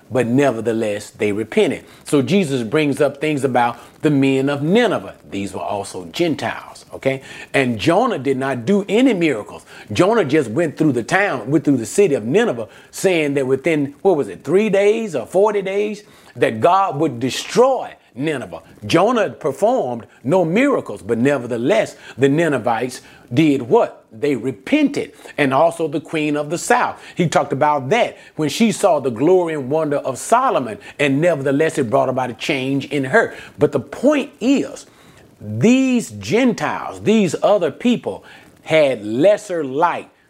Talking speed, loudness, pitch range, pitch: 160 wpm, -18 LUFS, 135-190 Hz, 150 Hz